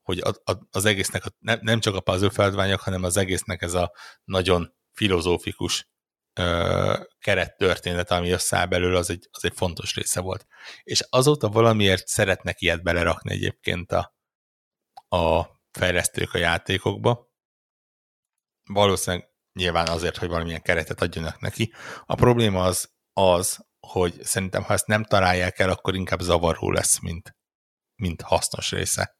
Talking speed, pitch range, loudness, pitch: 130 wpm, 90-105 Hz, -23 LUFS, 95 Hz